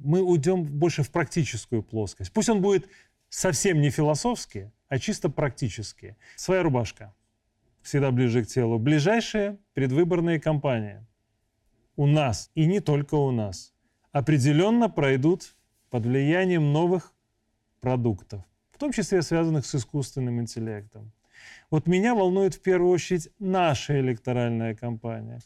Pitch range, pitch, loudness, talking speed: 115-175 Hz, 140 Hz, -25 LUFS, 125 wpm